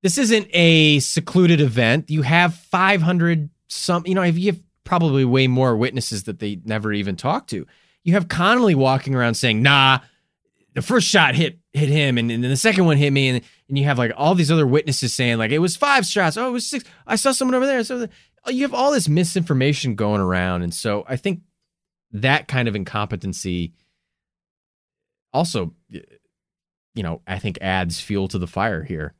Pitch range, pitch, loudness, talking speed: 115-180 Hz, 145 Hz, -19 LUFS, 195 wpm